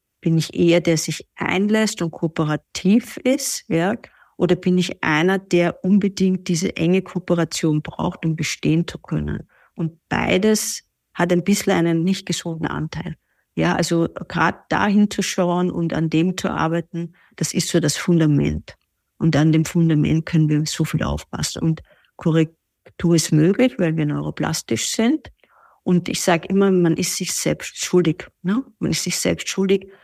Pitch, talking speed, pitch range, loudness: 175 Hz, 160 wpm, 160-190 Hz, -20 LUFS